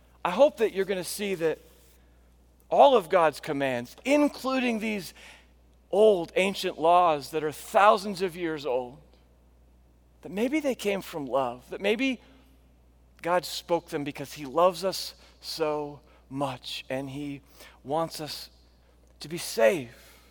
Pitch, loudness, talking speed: 150 Hz, -27 LUFS, 140 wpm